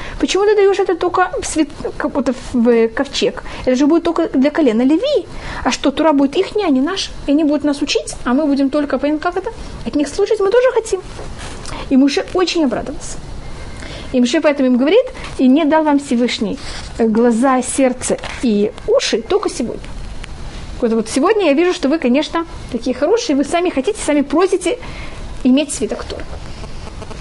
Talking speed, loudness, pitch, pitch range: 185 wpm, -16 LUFS, 295 Hz, 265-360 Hz